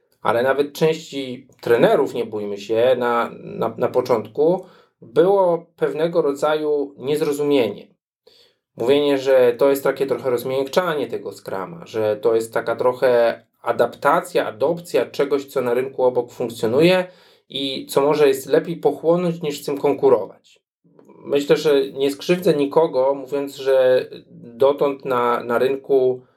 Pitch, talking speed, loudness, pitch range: 145 Hz, 130 wpm, -20 LUFS, 135-195 Hz